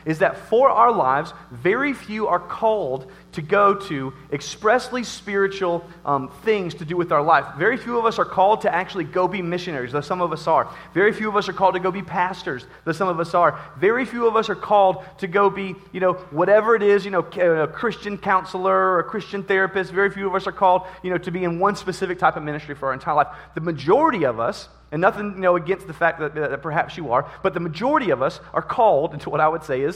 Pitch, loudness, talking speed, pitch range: 185 Hz, -21 LUFS, 250 wpm, 170-200 Hz